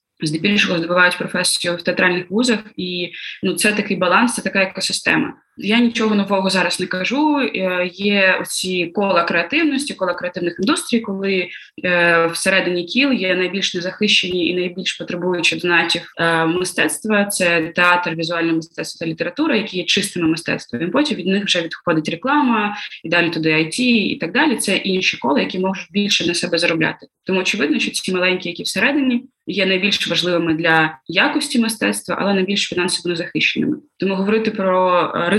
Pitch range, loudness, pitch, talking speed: 175-210 Hz, -17 LUFS, 185 Hz, 155 wpm